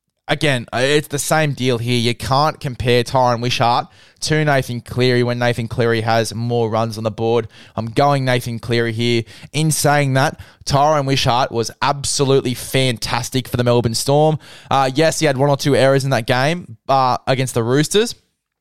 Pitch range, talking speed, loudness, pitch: 120-140 Hz, 175 wpm, -17 LUFS, 125 Hz